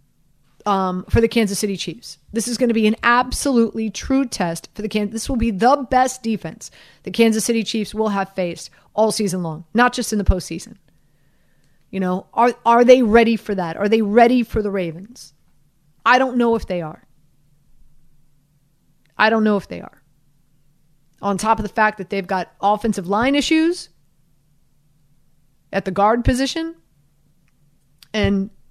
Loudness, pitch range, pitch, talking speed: -19 LUFS, 155-225 Hz, 200 Hz, 170 wpm